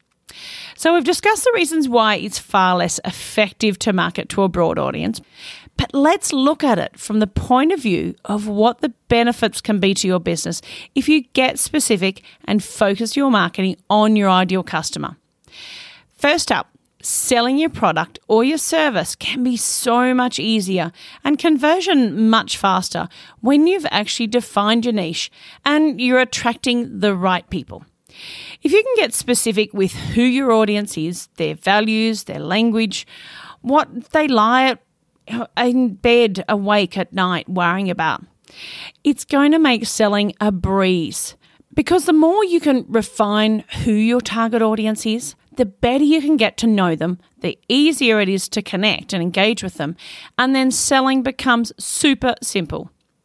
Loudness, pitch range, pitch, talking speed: -17 LUFS, 195-270 Hz, 225 Hz, 160 wpm